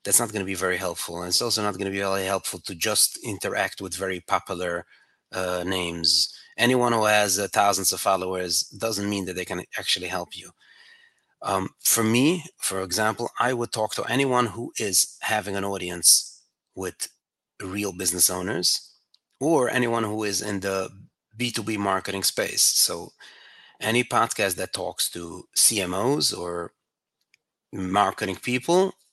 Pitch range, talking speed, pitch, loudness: 95-115 Hz, 160 wpm, 100 Hz, -23 LUFS